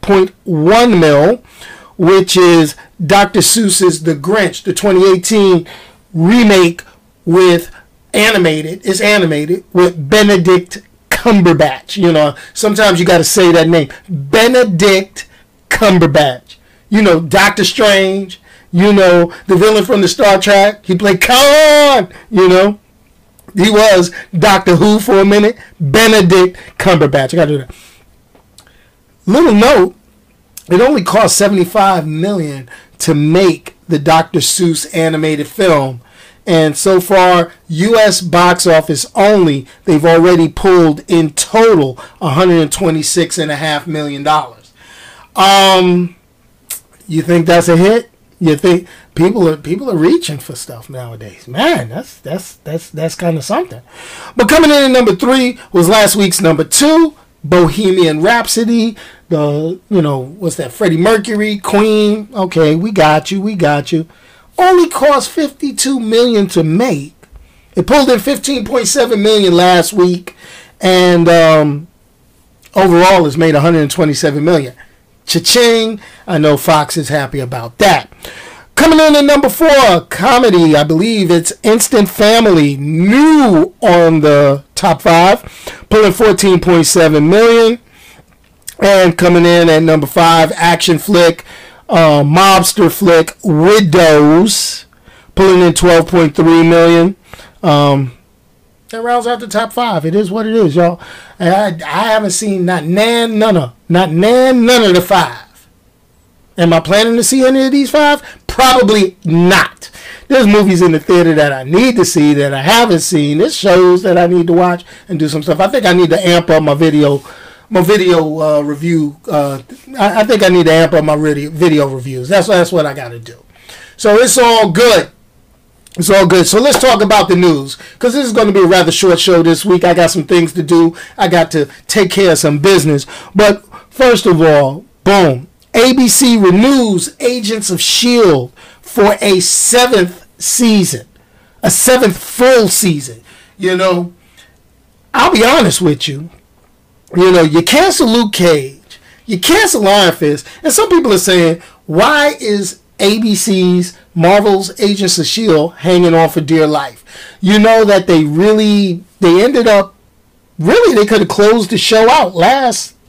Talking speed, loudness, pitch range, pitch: 150 wpm, -9 LUFS, 160-210 Hz, 180 Hz